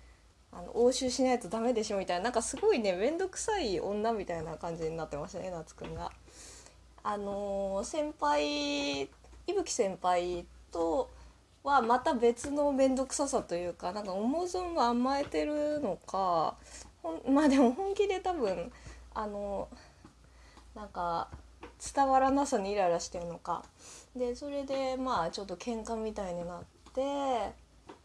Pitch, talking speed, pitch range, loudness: 230 Hz, 280 characters per minute, 175-275 Hz, -32 LUFS